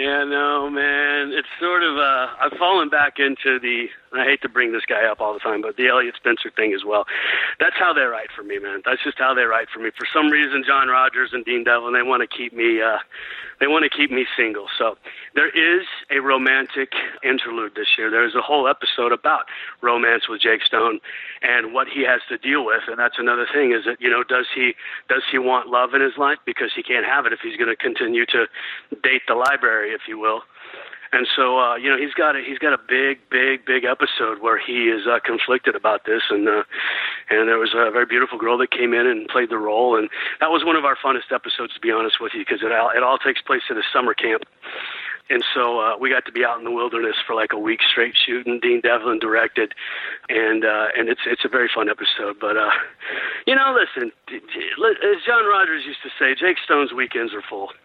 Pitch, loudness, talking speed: 140 Hz, -19 LUFS, 240 wpm